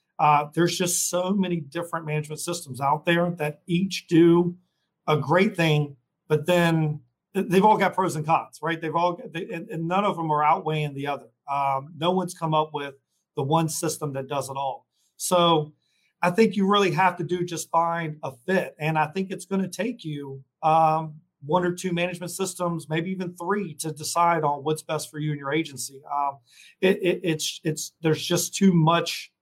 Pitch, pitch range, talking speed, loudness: 165 Hz, 150-180 Hz, 190 wpm, -24 LUFS